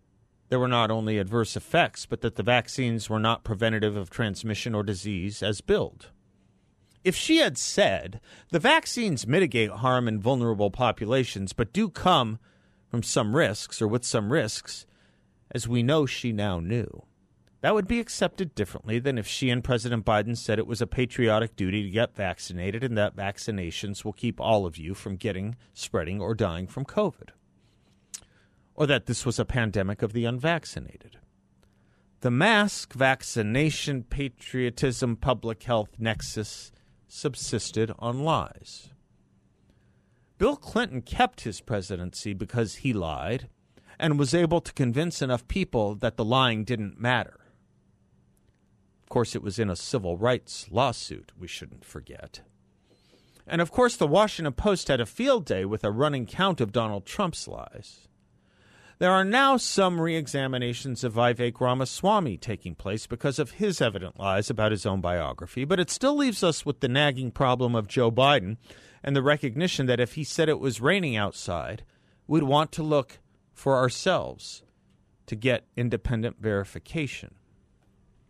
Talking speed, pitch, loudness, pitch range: 155 wpm, 120 Hz, -26 LUFS, 105-140 Hz